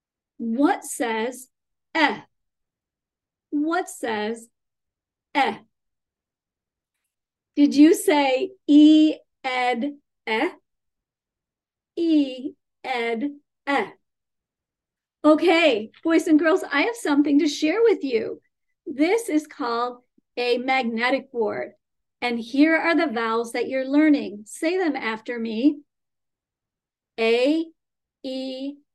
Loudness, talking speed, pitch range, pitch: -22 LUFS, 95 wpm, 245-315 Hz, 285 Hz